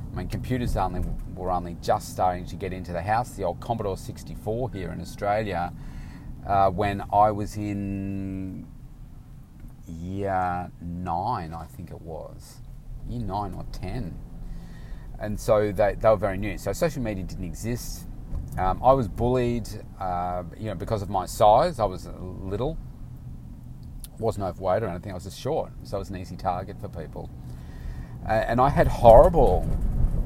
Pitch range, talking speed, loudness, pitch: 90-110 Hz, 165 wpm, -26 LUFS, 95 Hz